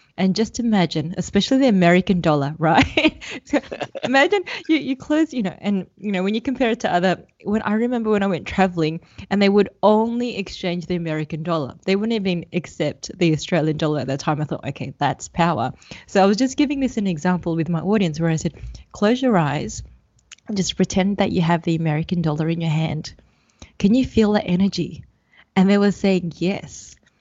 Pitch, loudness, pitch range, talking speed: 185 Hz, -20 LUFS, 165-215 Hz, 205 wpm